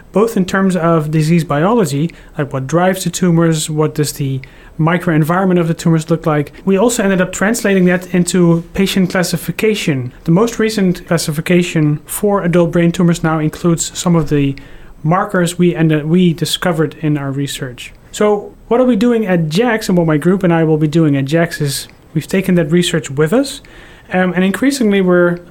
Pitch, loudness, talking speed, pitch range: 170 Hz, -14 LUFS, 185 wpm, 155-190 Hz